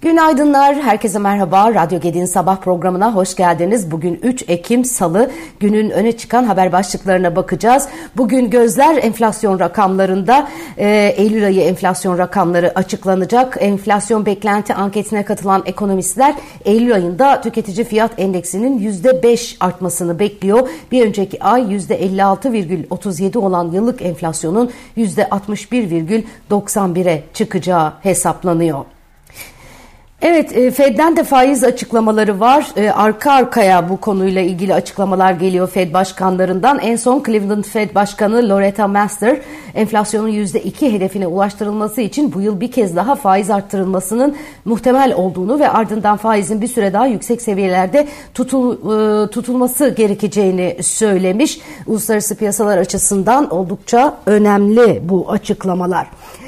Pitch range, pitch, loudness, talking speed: 190-240 Hz, 210 Hz, -14 LUFS, 115 wpm